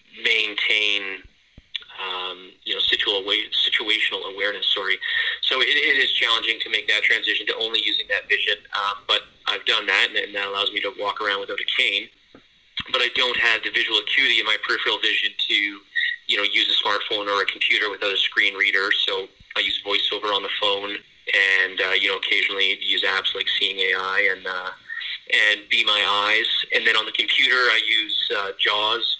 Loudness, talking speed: -20 LUFS, 195 wpm